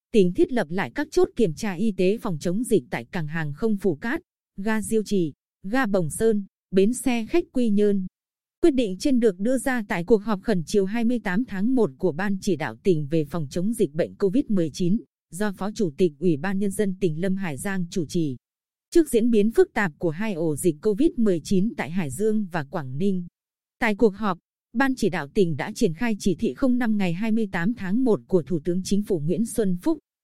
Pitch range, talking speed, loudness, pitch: 185-225 Hz, 220 wpm, -24 LUFS, 200 Hz